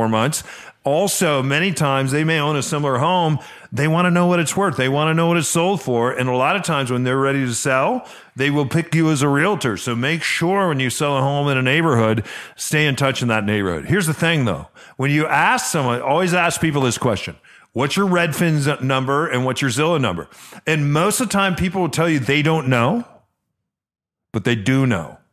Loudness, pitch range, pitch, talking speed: -18 LUFS, 130-165 Hz, 145 Hz, 230 wpm